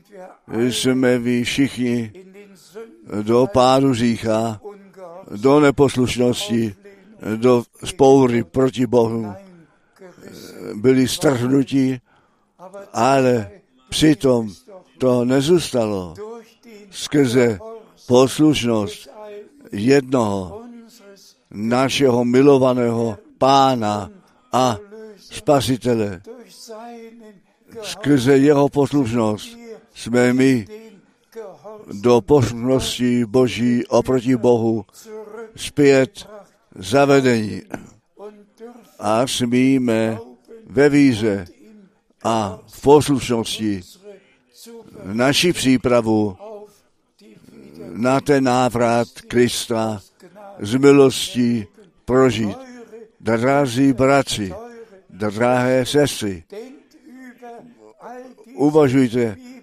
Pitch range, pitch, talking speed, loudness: 120-195 Hz, 135 Hz, 60 wpm, -17 LUFS